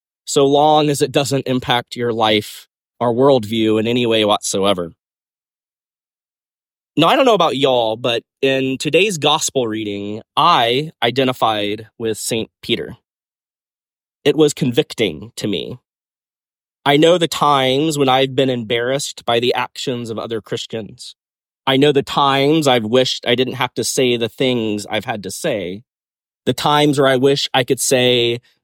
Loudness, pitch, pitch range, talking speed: -16 LUFS, 130 Hz, 115-140 Hz, 155 wpm